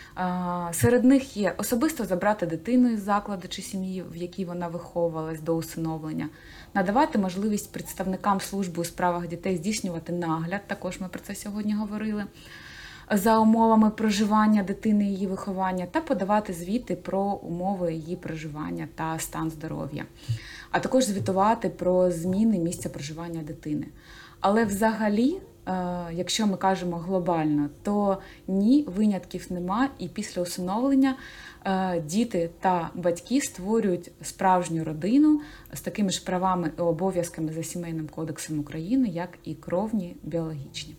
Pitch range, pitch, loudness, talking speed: 170-210 Hz, 185 Hz, -27 LUFS, 130 wpm